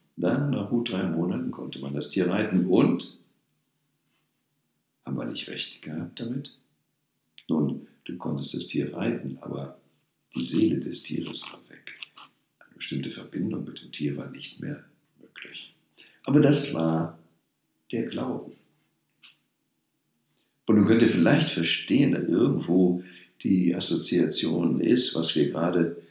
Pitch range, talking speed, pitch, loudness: 75-90 Hz, 135 wpm, 85 Hz, -26 LUFS